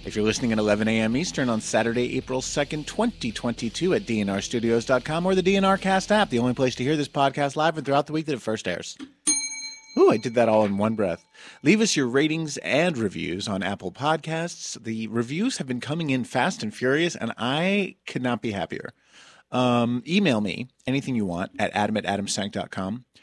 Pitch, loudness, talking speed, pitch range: 130 Hz, -24 LUFS, 200 wpm, 115-165 Hz